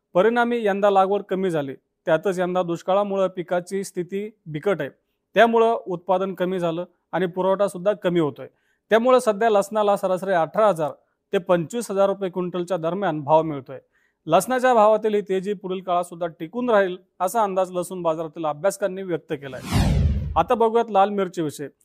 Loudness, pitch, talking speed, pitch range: -22 LUFS, 185 Hz, 155 wpm, 175-205 Hz